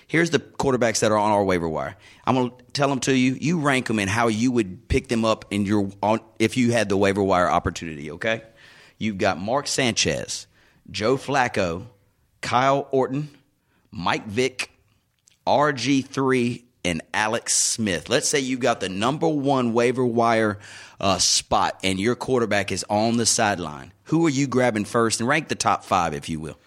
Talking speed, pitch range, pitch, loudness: 180 wpm, 100-130 Hz, 115 Hz, -22 LUFS